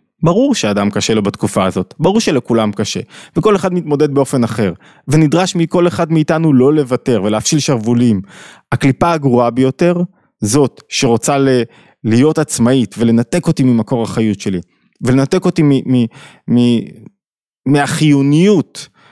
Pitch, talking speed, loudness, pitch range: 135 Hz, 130 wpm, -13 LUFS, 115-160 Hz